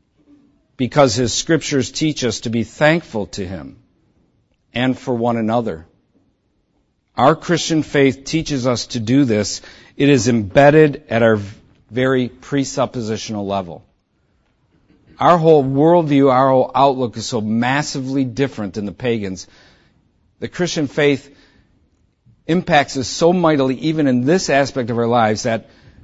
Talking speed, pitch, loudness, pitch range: 135 wpm, 130 Hz, -17 LUFS, 115-145 Hz